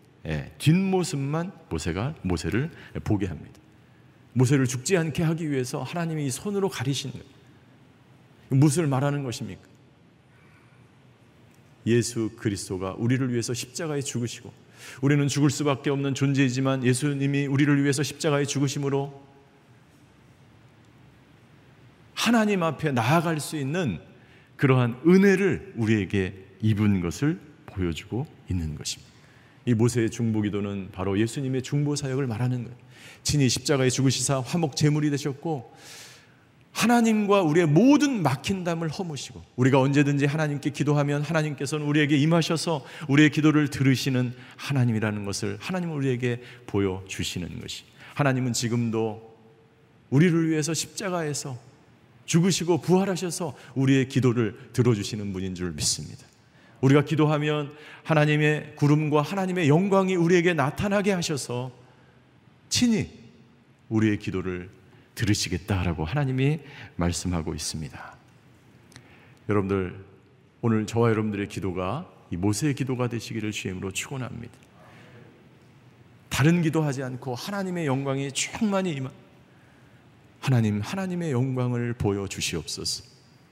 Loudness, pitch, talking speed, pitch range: -25 LUFS, 135 Hz, 315 characters per minute, 120-150 Hz